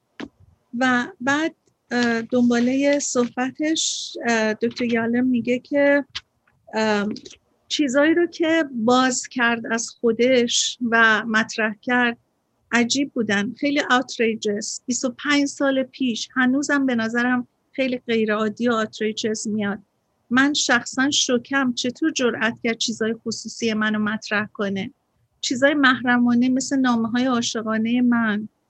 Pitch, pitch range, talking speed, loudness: 245 Hz, 225-265 Hz, 105 wpm, -21 LUFS